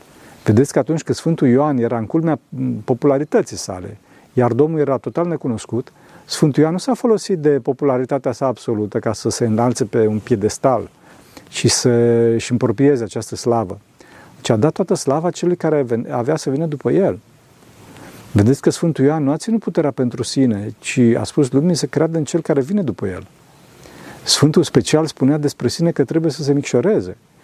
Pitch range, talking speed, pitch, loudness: 120-155 Hz, 180 wpm, 135 Hz, -17 LUFS